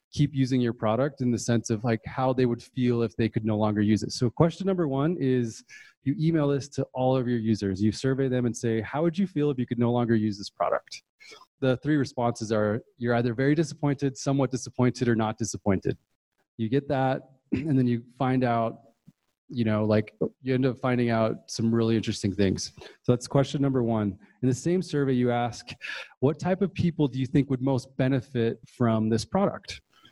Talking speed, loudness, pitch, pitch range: 215 wpm, -27 LUFS, 125 Hz, 115-135 Hz